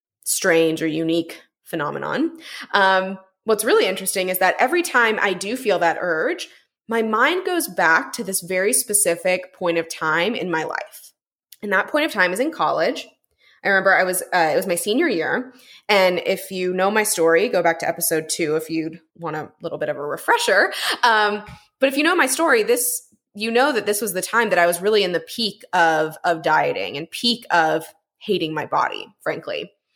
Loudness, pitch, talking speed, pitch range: -20 LUFS, 190 Hz, 200 wpm, 165-235 Hz